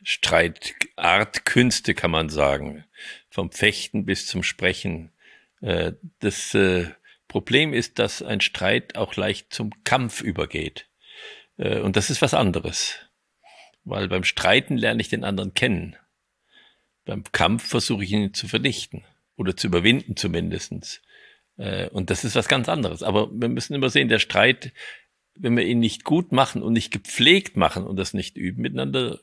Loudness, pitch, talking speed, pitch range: -22 LUFS, 100 Hz, 150 wpm, 80-120 Hz